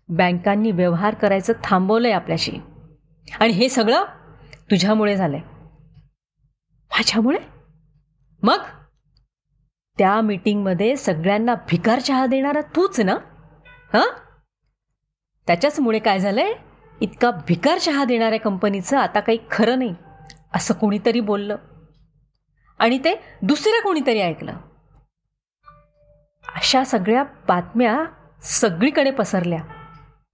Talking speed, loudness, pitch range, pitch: 85 wpm, -19 LUFS, 155-235 Hz, 205 Hz